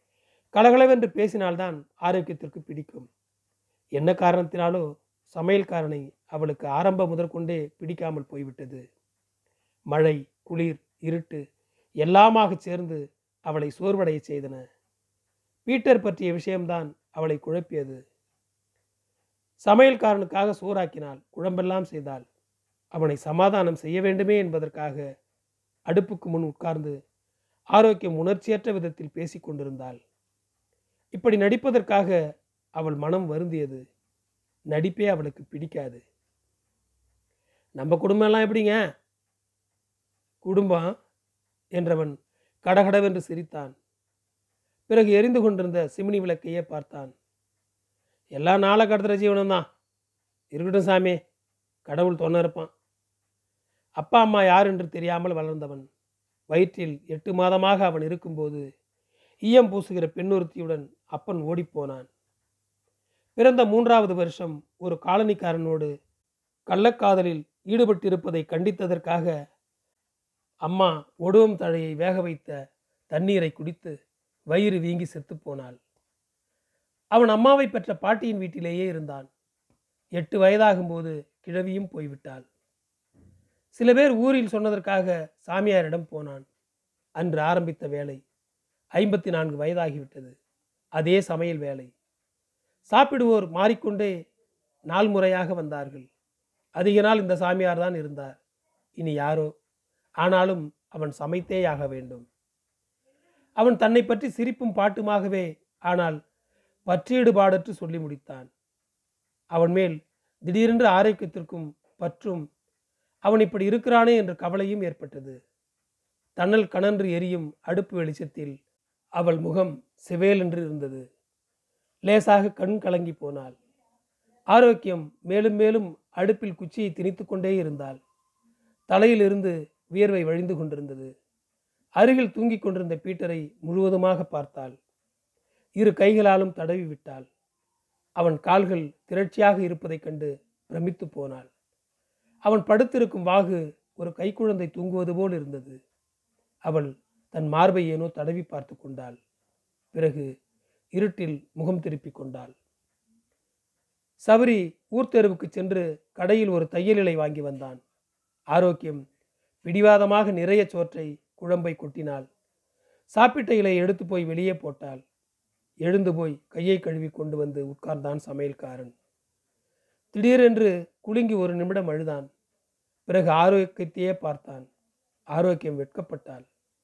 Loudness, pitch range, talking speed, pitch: -24 LUFS, 145-195 Hz, 90 wpm, 170 Hz